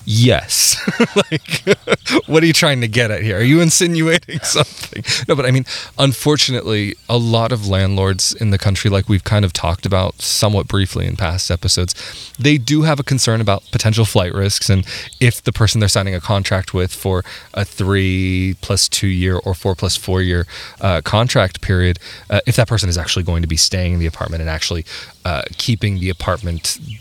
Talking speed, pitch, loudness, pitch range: 195 wpm, 100 Hz, -16 LUFS, 95-120 Hz